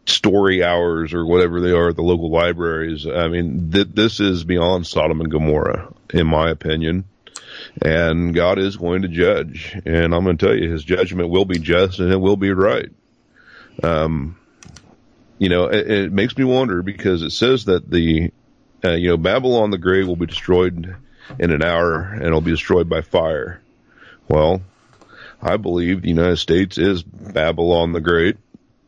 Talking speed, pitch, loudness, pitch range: 175 wpm, 85 Hz, -18 LUFS, 85-95 Hz